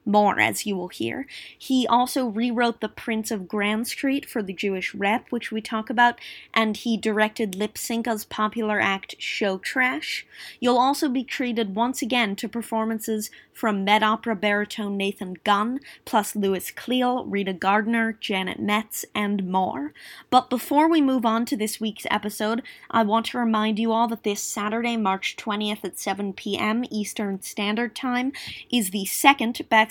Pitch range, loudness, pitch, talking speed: 210-240 Hz, -24 LUFS, 220 Hz, 165 wpm